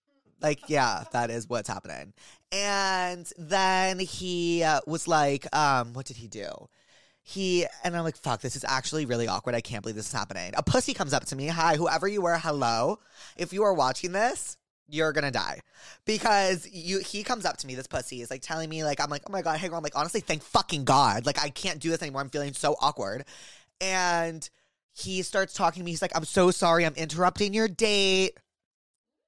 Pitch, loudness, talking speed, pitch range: 165 Hz, -27 LUFS, 210 wpm, 140-185 Hz